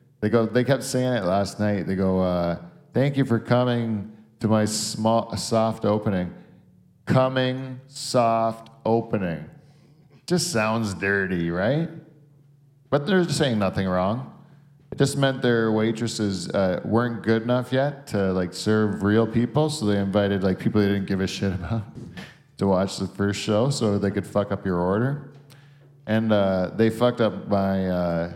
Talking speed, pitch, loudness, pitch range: 165 wpm, 115 Hz, -23 LUFS, 100-130 Hz